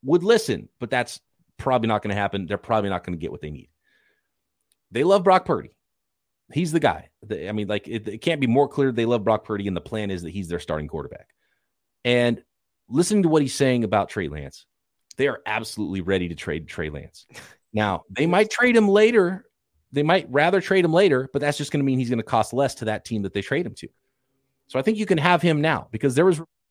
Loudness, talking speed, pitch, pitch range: -22 LUFS, 240 wpm, 120 Hz, 100-160 Hz